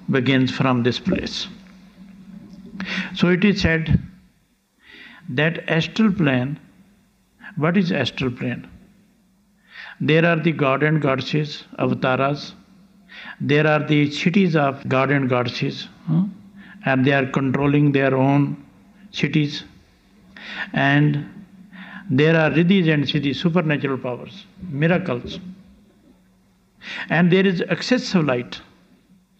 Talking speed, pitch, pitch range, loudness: 100 wpm, 170 Hz, 145-195 Hz, -20 LUFS